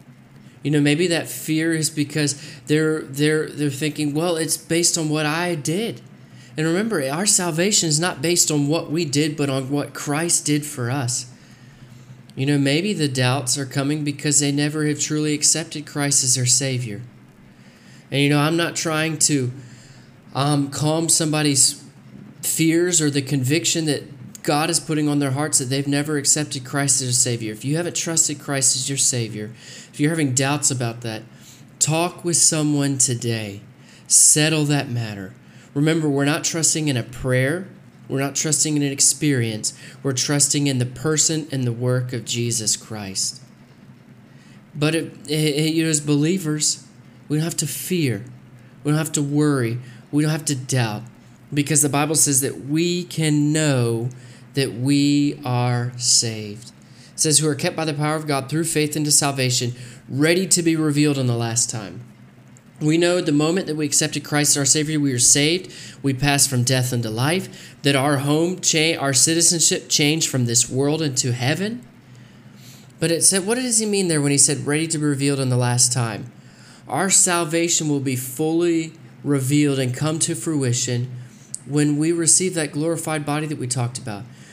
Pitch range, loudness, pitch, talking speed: 130-155 Hz, -19 LUFS, 145 Hz, 180 wpm